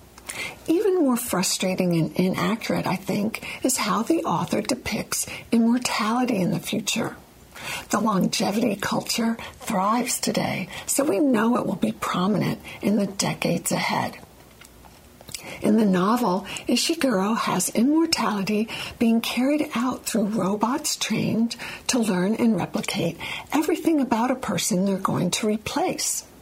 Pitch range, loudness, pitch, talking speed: 190-250 Hz, -23 LUFS, 220 Hz, 125 wpm